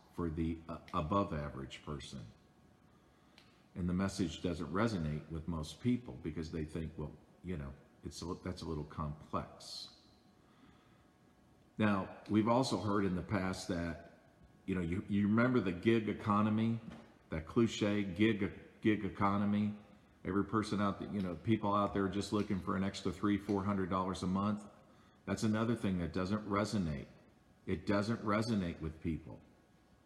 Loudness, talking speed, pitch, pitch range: -37 LUFS, 160 wpm, 100 Hz, 85-105 Hz